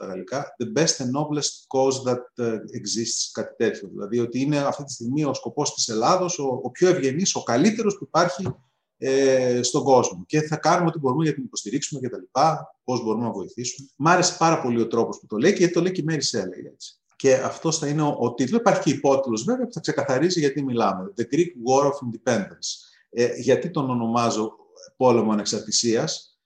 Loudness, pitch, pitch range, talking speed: -23 LUFS, 135 Hz, 120-160 Hz, 210 wpm